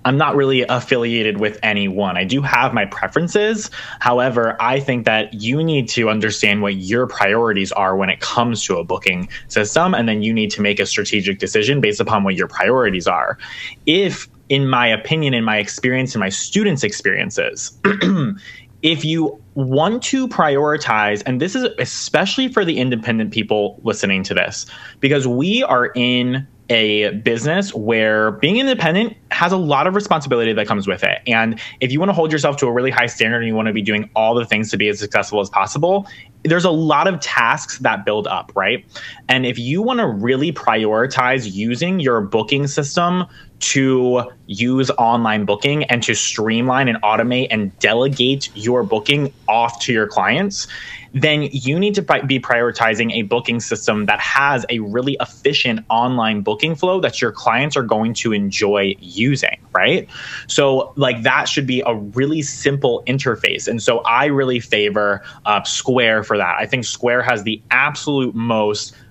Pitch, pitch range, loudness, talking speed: 120 Hz, 110-140 Hz, -17 LUFS, 175 wpm